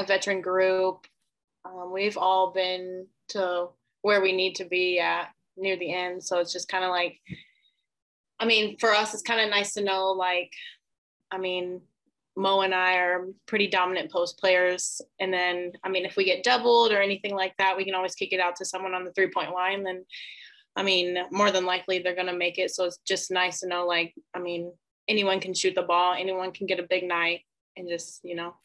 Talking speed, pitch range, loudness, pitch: 215 wpm, 180-195 Hz, -26 LUFS, 185 Hz